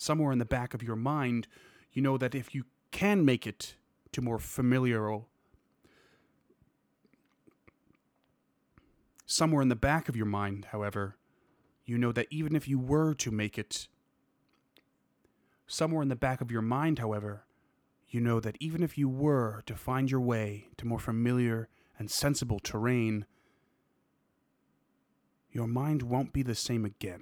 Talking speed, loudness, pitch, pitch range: 150 wpm, -32 LUFS, 120 Hz, 110-135 Hz